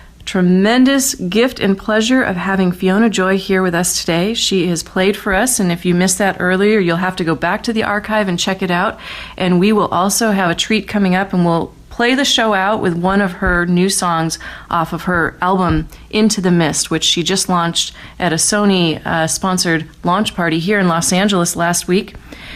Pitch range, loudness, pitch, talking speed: 175-205 Hz, -15 LUFS, 185 Hz, 215 wpm